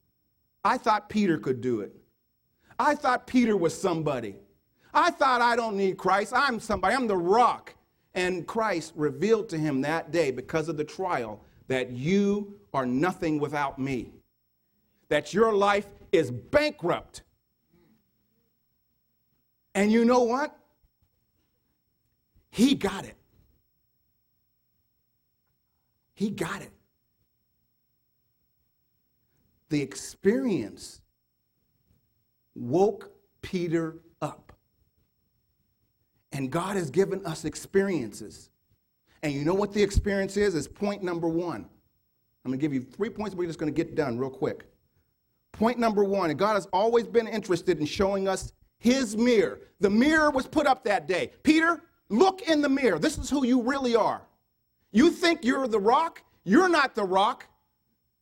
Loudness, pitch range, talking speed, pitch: -26 LUFS, 150-235 Hz, 135 wpm, 195 Hz